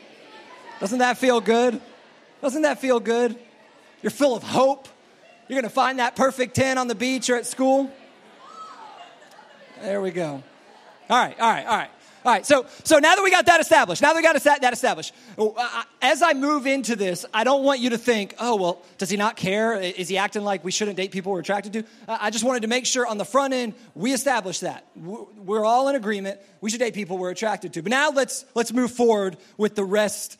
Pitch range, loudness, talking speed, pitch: 205-265 Hz, -22 LUFS, 215 wpm, 235 Hz